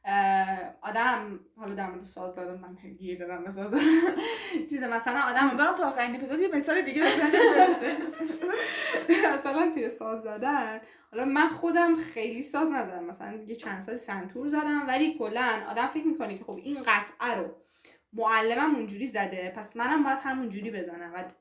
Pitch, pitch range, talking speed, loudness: 250 Hz, 205-310 Hz, 155 wpm, -27 LUFS